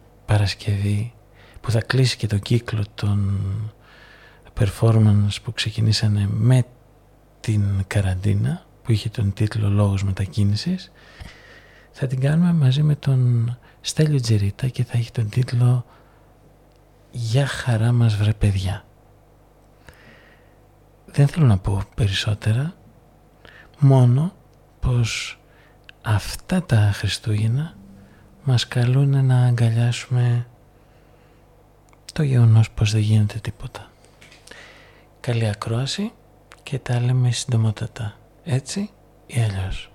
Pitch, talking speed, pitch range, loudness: 115 Hz, 100 wpm, 105-125 Hz, -21 LUFS